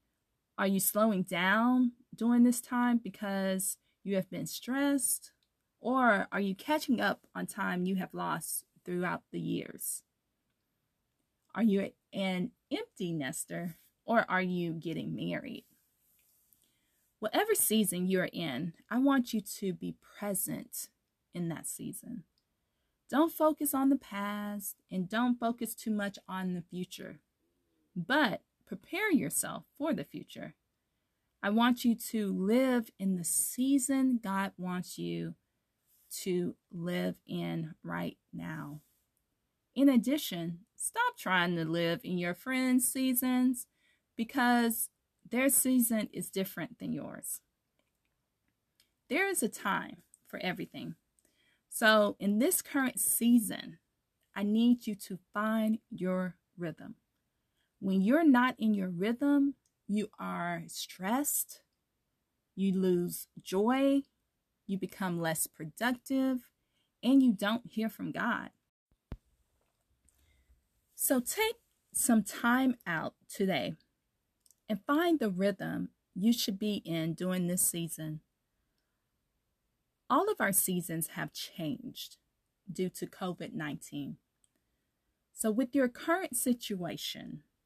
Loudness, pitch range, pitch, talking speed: -32 LUFS, 185-250 Hz, 210 Hz, 120 wpm